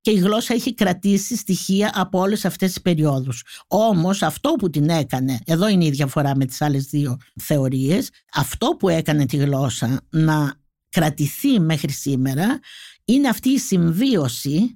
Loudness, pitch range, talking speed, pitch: -20 LUFS, 140-200 Hz, 155 wpm, 165 Hz